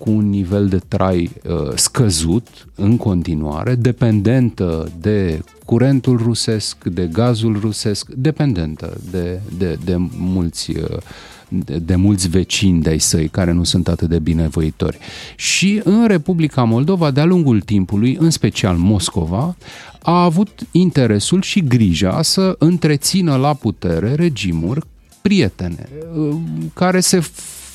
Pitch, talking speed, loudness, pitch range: 110 Hz, 130 wpm, -16 LUFS, 90-150 Hz